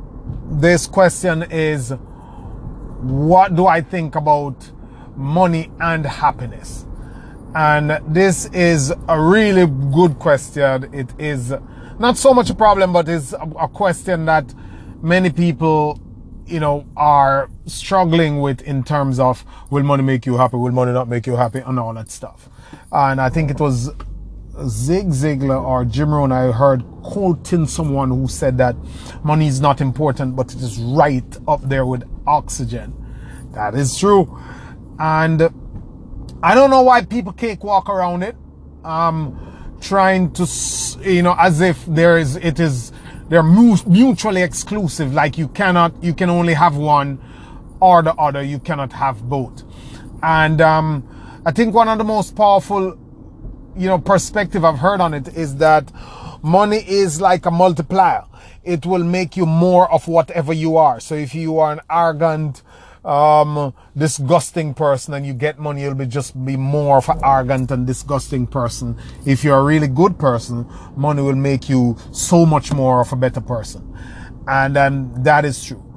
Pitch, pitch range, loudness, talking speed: 150 Hz, 130-170 Hz, -16 LUFS, 160 wpm